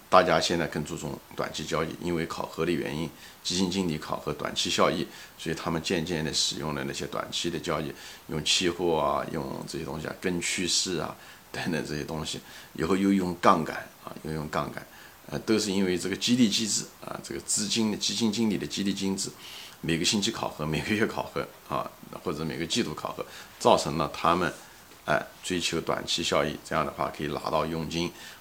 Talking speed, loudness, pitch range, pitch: 305 characters per minute, -28 LUFS, 80-100 Hz, 85 Hz